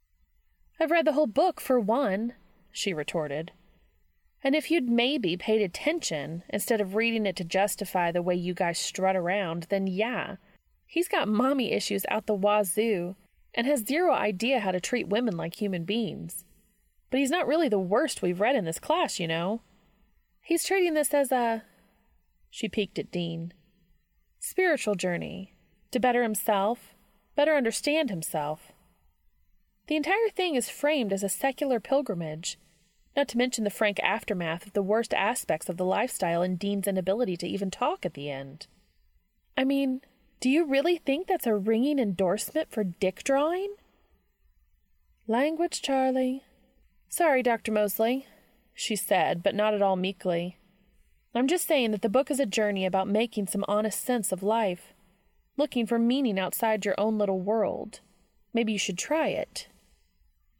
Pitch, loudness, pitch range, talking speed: 210 Hz, -28 LUFS, 185-260 Hz, 160 wpm